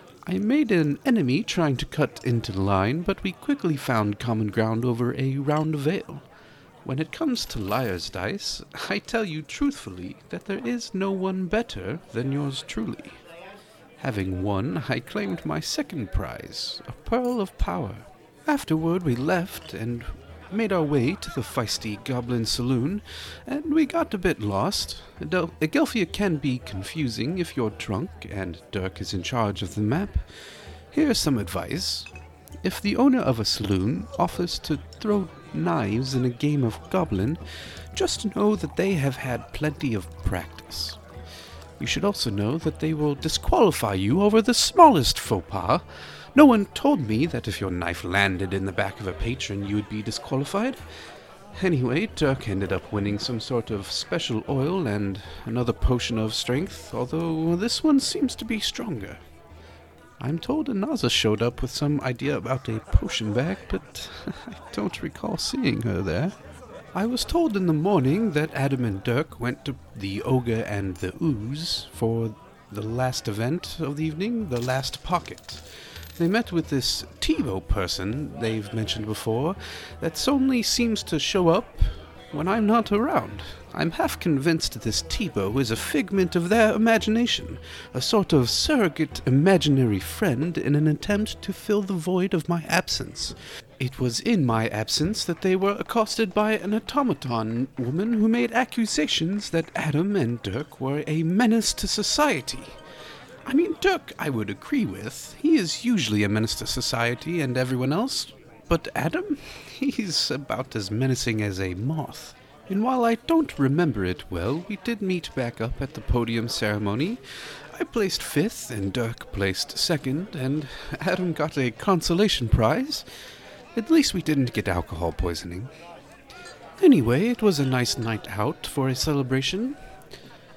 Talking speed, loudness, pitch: 165 wpm, -25 LUFS, 140 Hz